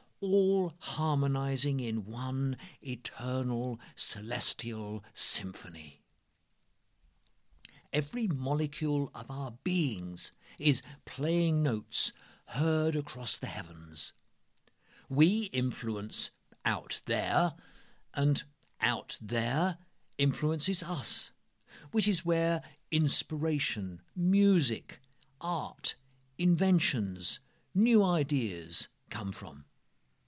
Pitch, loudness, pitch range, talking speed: 140 Hz, -32 LUFS, 115-160 Hz, 75 wpm